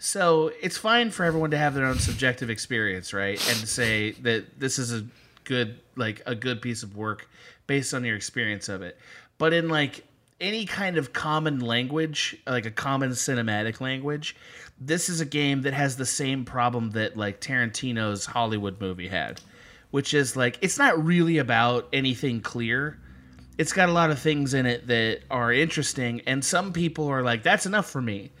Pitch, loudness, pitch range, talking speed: 130 Hz, -25 LUFS, 115-150 Hz, 185 wpm